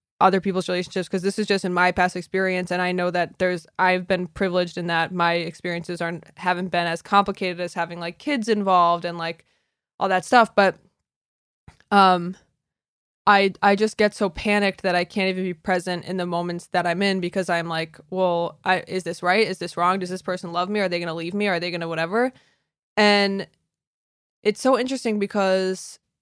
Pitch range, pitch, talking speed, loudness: 175-195 Hz, 185 Hz, 200 wpm, -22 LUFS